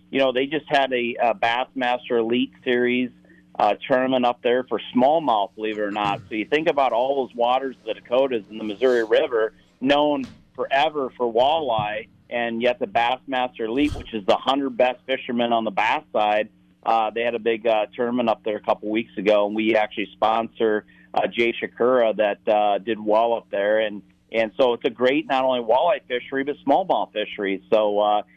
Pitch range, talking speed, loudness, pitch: 105-125 Hz, 200 wpm, -22 LUFS, 115 Hz